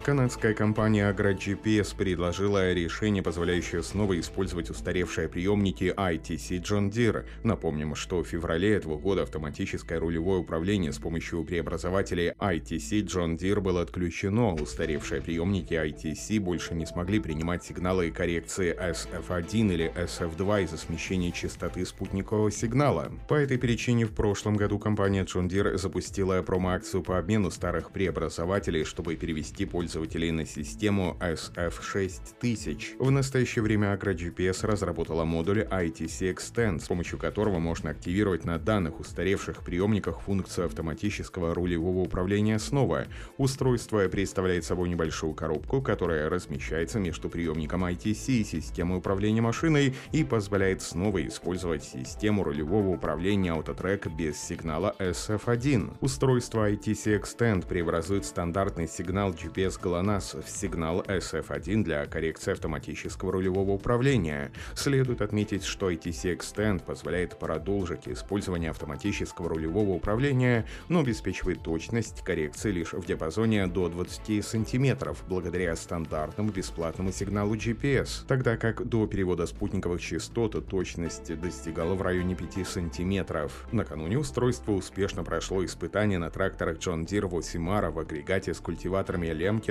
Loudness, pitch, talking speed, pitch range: -29 LUFS, 95 Hz, 125 wpm, 85-105 Hz